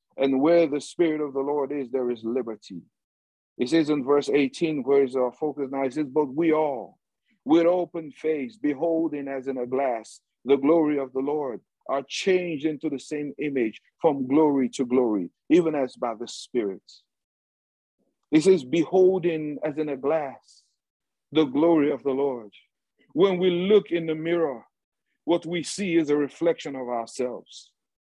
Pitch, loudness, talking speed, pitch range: 150 Hz, -25 LUFS, 170 wpm, 135-165 Hz